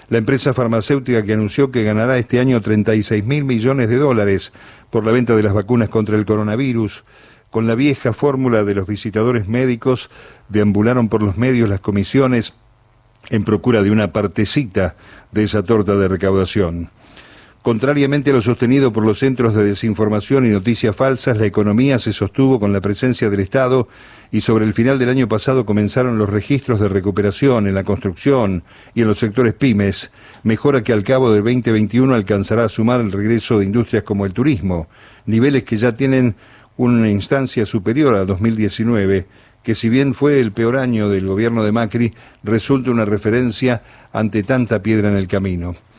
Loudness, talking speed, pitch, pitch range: -16 LUFS, 175 wpm, 115 Hz, 105-125 Hz